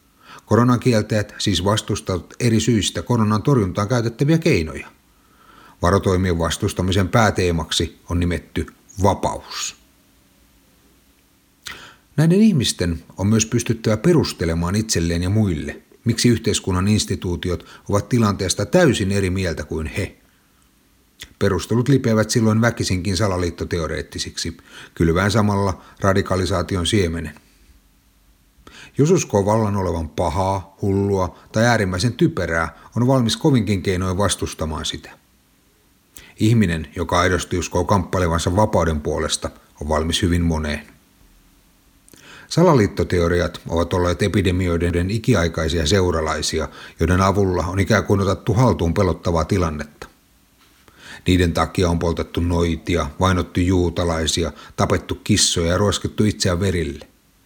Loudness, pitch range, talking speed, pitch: -19 LUFS, 85-105 Hz, 100 wpm, 95 Hz